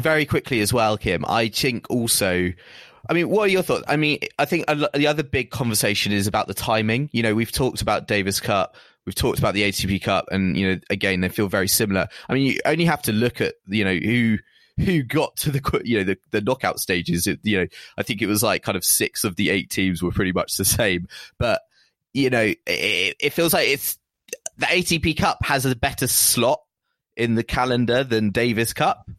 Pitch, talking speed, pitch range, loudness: 115 Hz, 225 wpm, 100-145 Hz, -21 LUFS